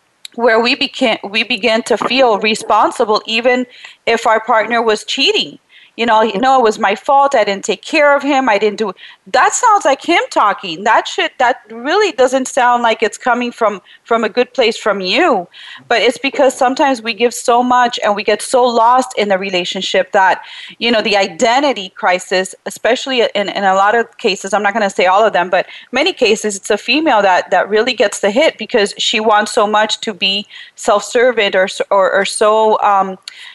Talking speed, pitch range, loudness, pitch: 200 wpm, 205-255 Hz, -13 LUFS, 225 Hz